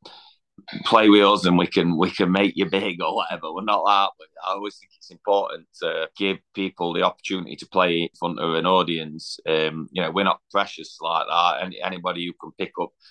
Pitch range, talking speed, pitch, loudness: 85-100 Hz, 215 wpm, 95 Hz, -22 LUFS